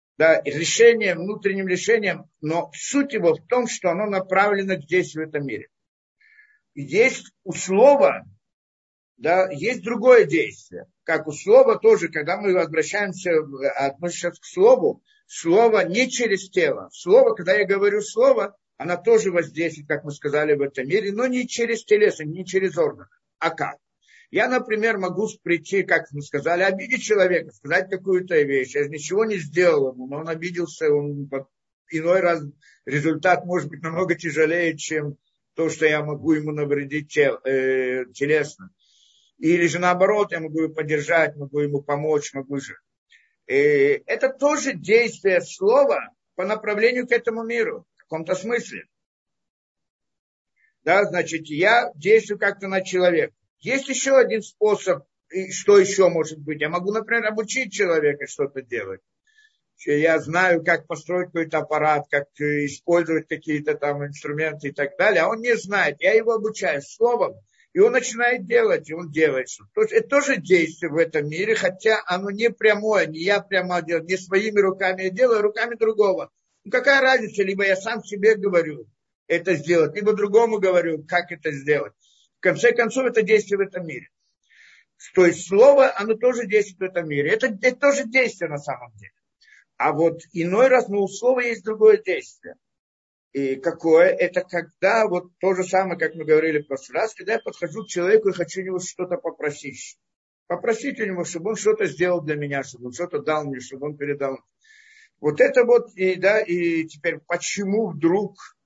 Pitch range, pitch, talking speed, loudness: 160-230 Hz, 185 Hz, 165 wpm, -21 LUFS